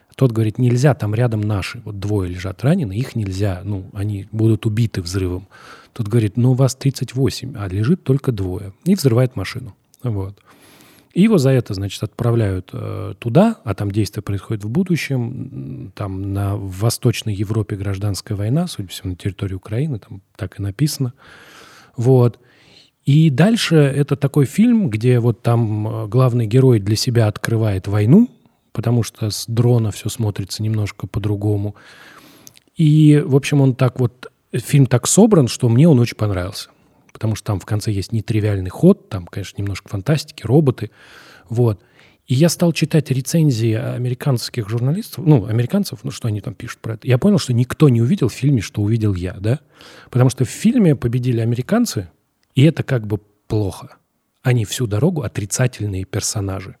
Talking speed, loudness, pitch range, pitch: 165 wpm, -18 LUFS, 105-135 Hz, 120 Hz